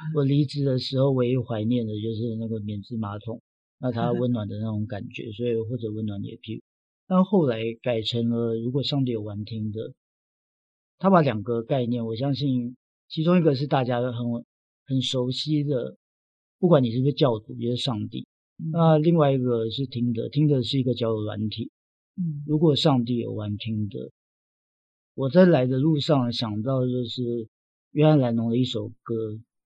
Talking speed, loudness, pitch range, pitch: 265 characters per minute, -25 LUFS, 110-140 Hz, 120 Hz